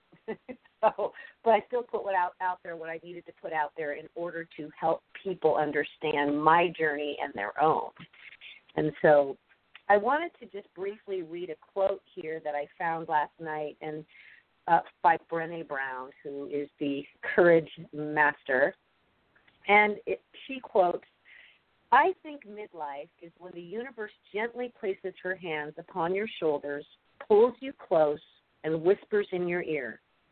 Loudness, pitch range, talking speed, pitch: -29 LUFS, 150-200 Hz, 155 wpm, 170 Hz